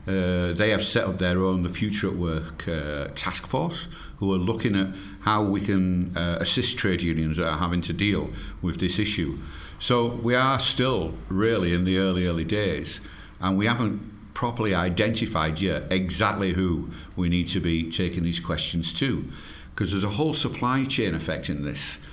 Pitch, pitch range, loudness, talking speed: 95 Hz, 85-105 Hz, -25 LUFS, 180 wpm